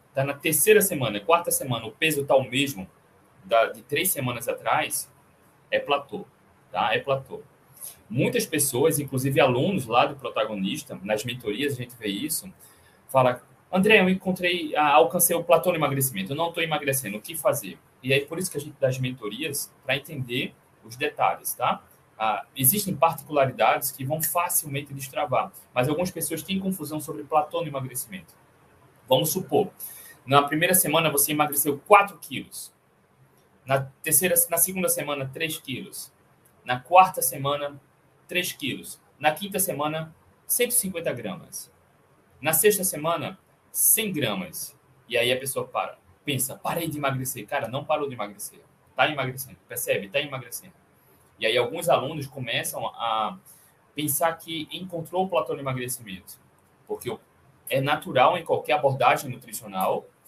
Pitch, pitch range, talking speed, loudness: 150 Hz, 135-170 Hz, 150 wpm, -24 LUFS